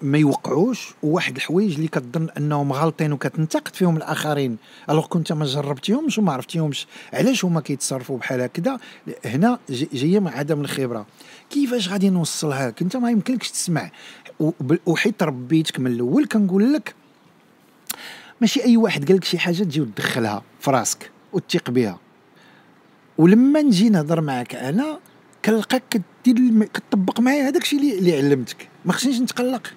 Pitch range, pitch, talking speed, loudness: 145-225 Hz, 175 Hz, 140 wpm, -21 LUFS